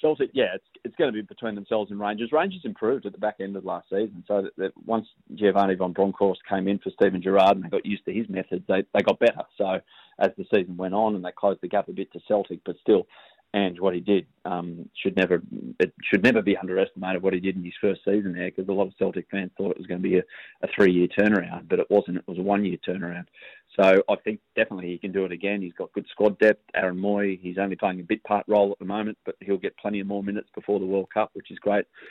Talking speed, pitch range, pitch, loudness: 275 wpm, 95-105 Hz, 100 Hz, -25 LUFS